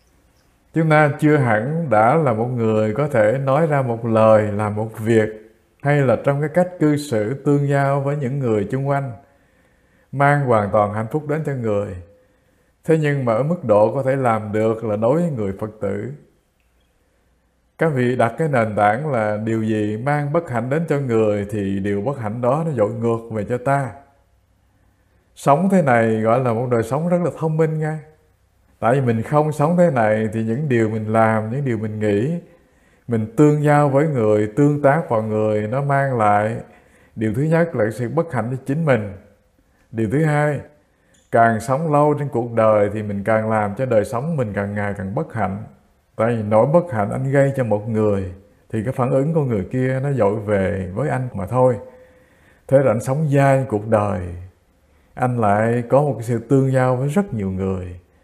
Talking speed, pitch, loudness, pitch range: 200 wpm, 115 Hz, -19 LUFS, 105-140 Hz